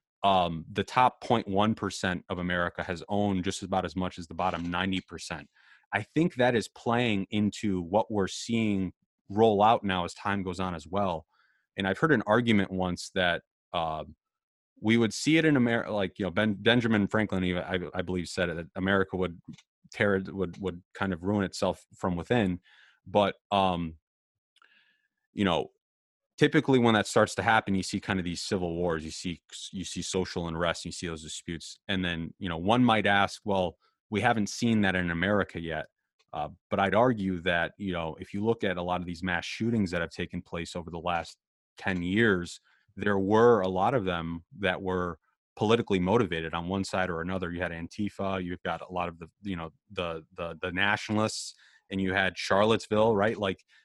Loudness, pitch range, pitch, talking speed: -29 LUFS, 90-105 Hz, 95 Hz, 200 wpm